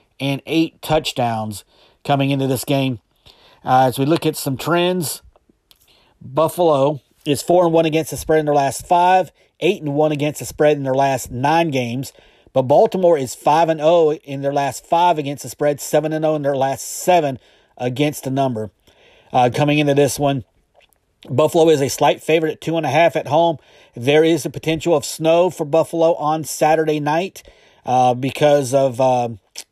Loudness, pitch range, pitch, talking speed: -17 LUFS, 135-160 Hz, 145 Hz, 190 wpm